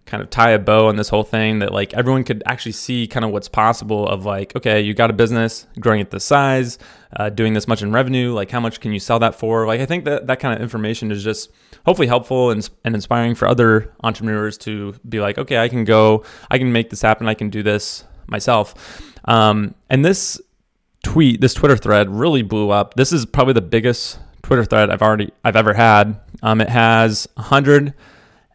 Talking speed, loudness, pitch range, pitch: 225 wpm, -16 LUFS, 105-120 Hz, 110 Hz